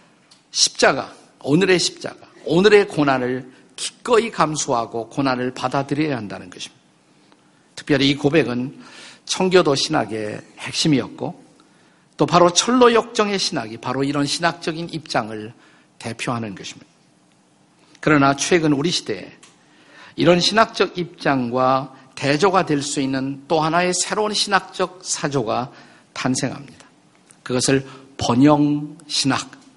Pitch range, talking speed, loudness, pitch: 130-175 Hz, 270 characters per minute, -19 LUFS, 145 Hz